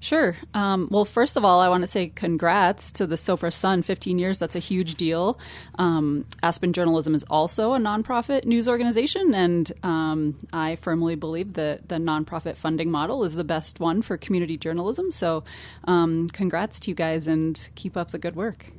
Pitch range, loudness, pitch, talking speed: 165-195 Hz, -24 LUFS, 175 Hz, 190 wpm